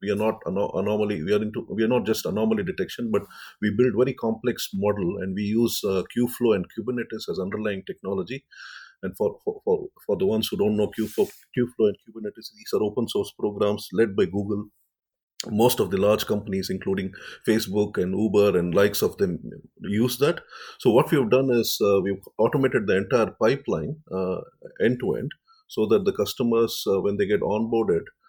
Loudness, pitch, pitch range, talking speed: -24 LUFS, 110 Hz, 105-125 Hz, 195 wpm